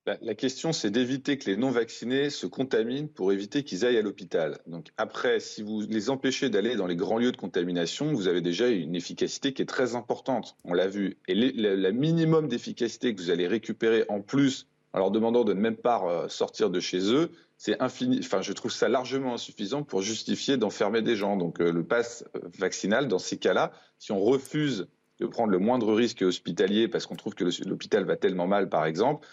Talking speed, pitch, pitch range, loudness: 210 wpm, 120 Hz, 100-135 Hz, -28 LUFS